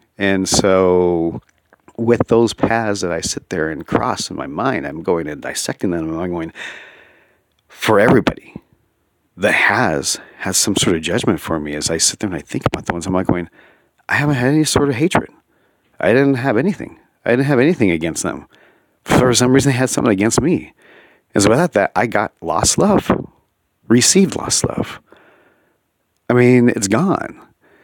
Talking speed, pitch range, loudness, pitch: 190 wpm, 90-130 Hz, -16 LUFS, 115 Hz